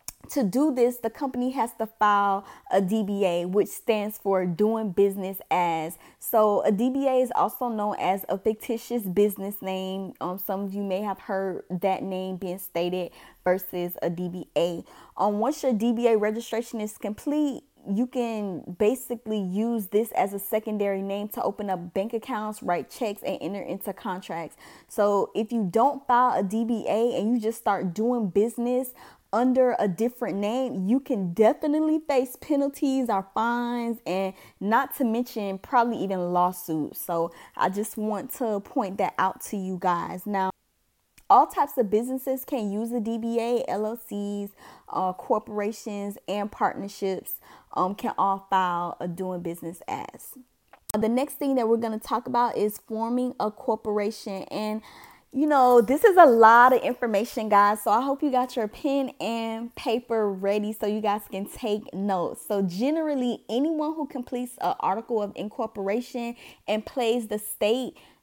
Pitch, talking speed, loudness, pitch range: 215 Hz, 160 wpm, -26 LUFS, 195-245 Hz